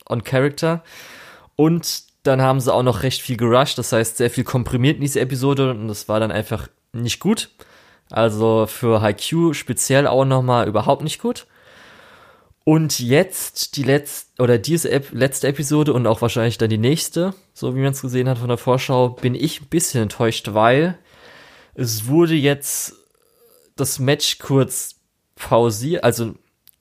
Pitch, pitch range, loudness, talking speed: 130 Hz, 120-150 Hz, -19 LUFS, 165 wpm